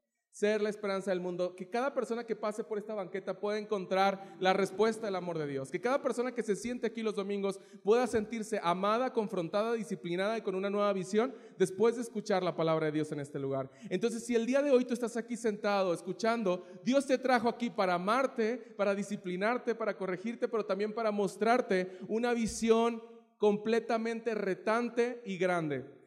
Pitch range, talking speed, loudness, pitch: 190-230 Hz, 185 wpm, -33 LUFS, 210 Hz